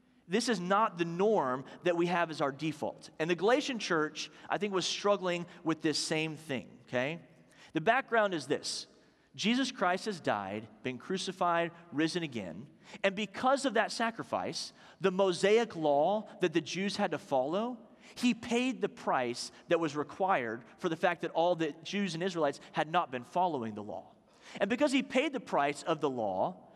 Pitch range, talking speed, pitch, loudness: 155-210 Hz, 180 wpm, 180 Hz, -32 LUFS